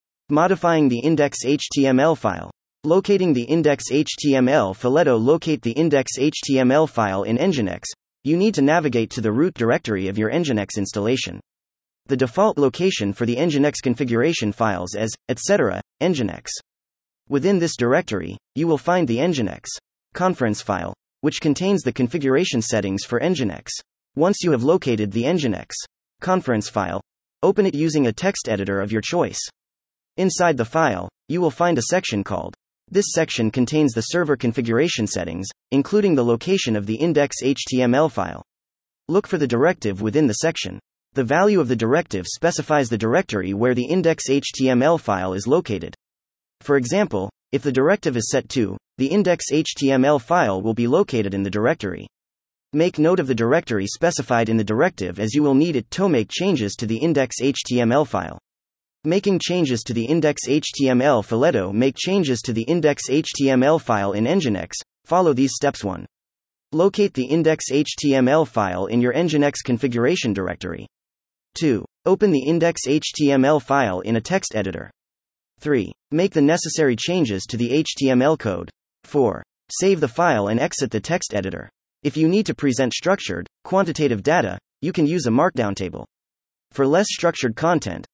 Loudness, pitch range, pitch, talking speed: -20 LUFS, 105-160 Hz, 130 Hz, 155 wpm